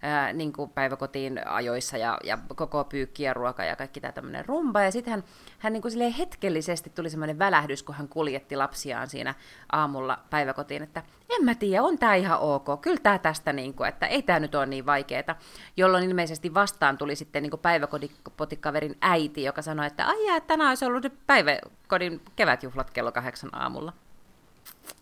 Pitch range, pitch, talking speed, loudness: 140-195 Hz, 155 Hz, 180 wpm, -27 LUFS